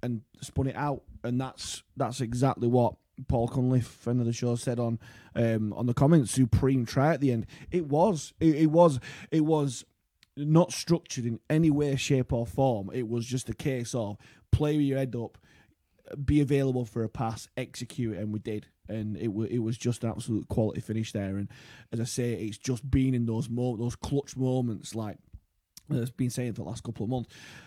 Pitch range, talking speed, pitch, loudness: 115-135 Hz, 210 wpm, 120 Hz, -29 LUFS